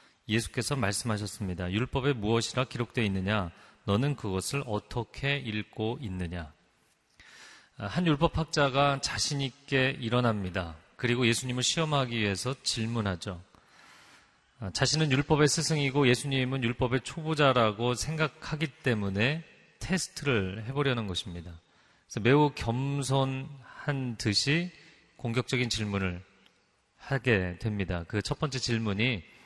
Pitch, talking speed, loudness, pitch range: 120 Hz, 285 characters per minute, -29 LUFS, 105-140 Hz